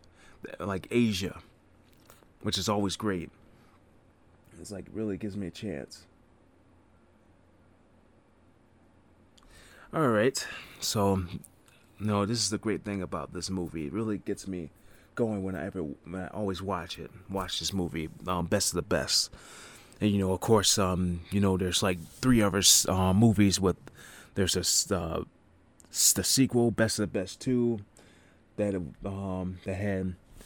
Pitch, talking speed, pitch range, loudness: 95 Hz, 150 wpm, 90-105 Hz, -28 LUFS